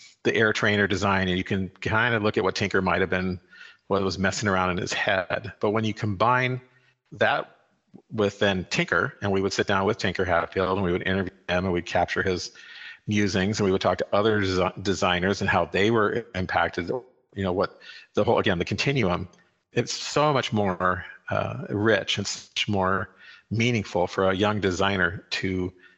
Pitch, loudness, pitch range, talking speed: 95 Hz, -25 LUFS, 95-105 Hz, 195 wpm